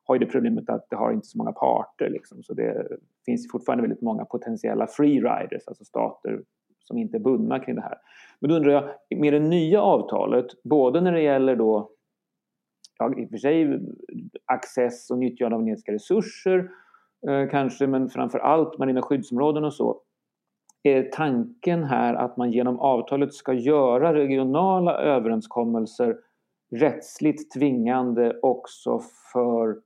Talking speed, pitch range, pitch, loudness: 155 wpm, 125-185 Hz, 145 Hz, -24 LUFS